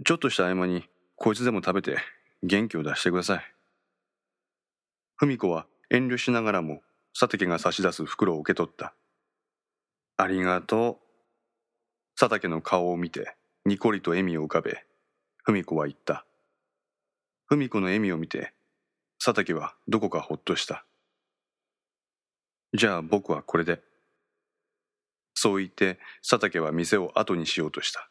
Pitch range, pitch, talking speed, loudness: 90-115 Hz, 95 Hz, 280 characters per minute, -27 LUFS